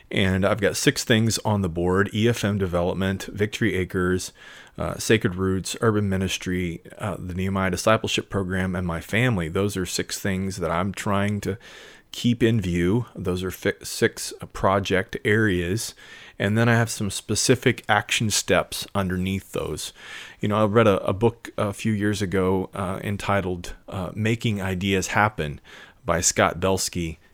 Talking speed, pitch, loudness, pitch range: 160 wpm, 100 Hz, -24 LUFS, 95-110 Hz